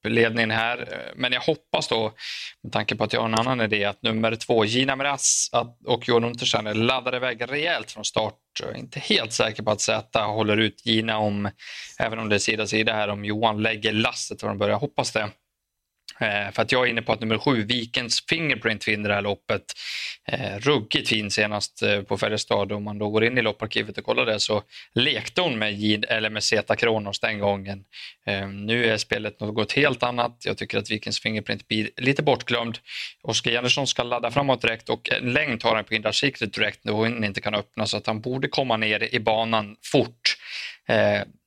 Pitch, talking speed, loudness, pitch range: 110 Hz, 205 wpm, -24 LUFS, 105-120 Hz